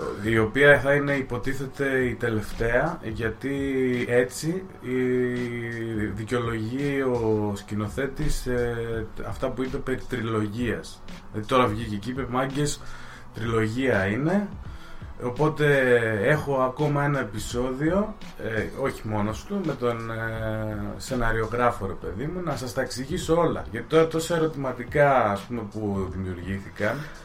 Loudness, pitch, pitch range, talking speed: -26 LUFS, 125 Hz, 110-140 Hz, 120 wpm